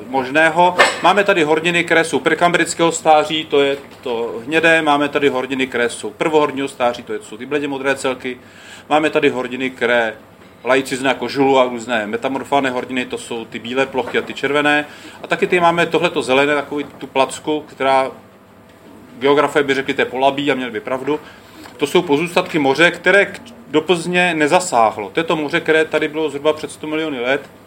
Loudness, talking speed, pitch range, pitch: -16 LUFS, 185 wpm, 130-160 Hz, 145 Hz